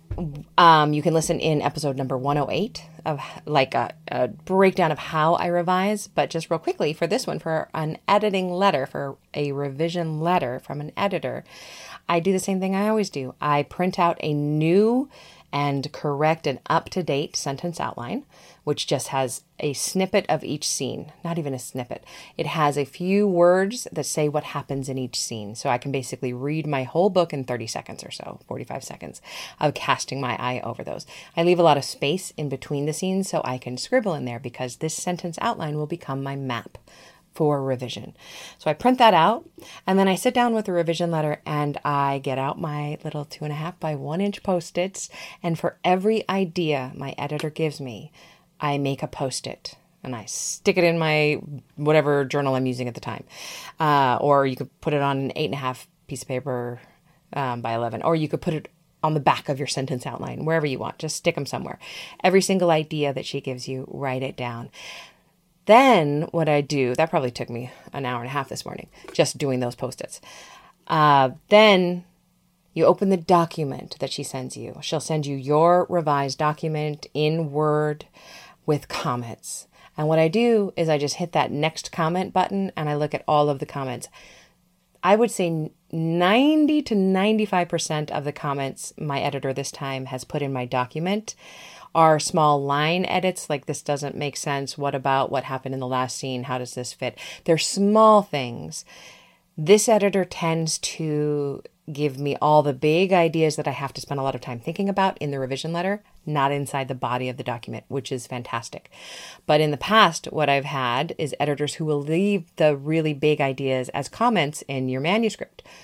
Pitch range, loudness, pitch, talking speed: 135-175 Hz, -23 LUFS, 150 Hz, 200 wpm